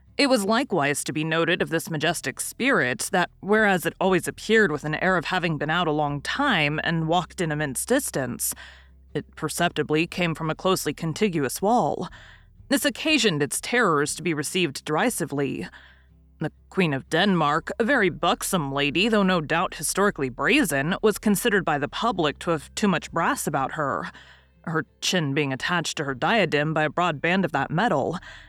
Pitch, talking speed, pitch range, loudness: 165 Hz, 180 wpm, 150-190 Hz, -23 LUFS